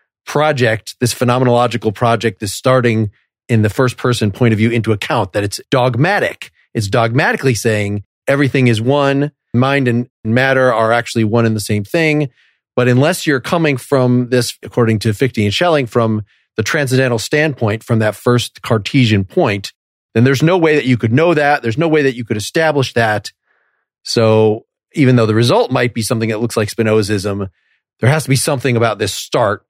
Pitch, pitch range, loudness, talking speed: 120 Hz, 110-135 Hz, -14 LUFS, 185 wpm